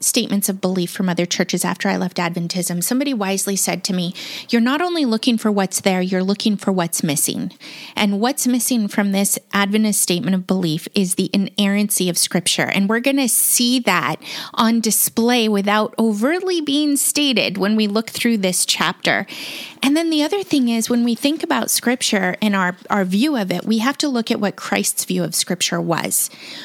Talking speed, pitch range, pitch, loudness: 195 wpm, 185-245 Hz, 210 Hz, -18 LUFS